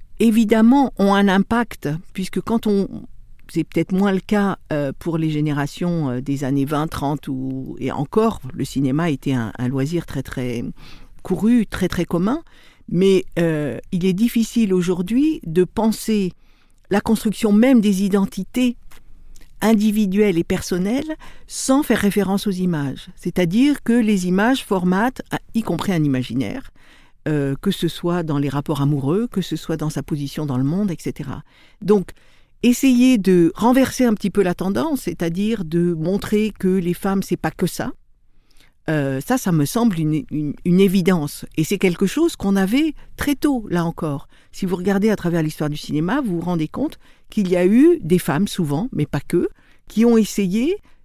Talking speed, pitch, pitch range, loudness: 170 wpm, 185 Hz, 155-215 Hz, -19 LUFS